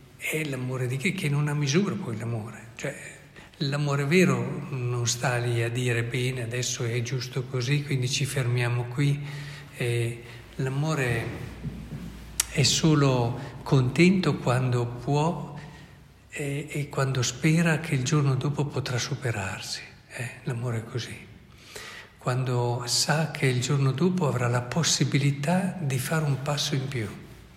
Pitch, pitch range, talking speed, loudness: 135 Hz, 120-145 Hz, 135 wpm, -26 LUFS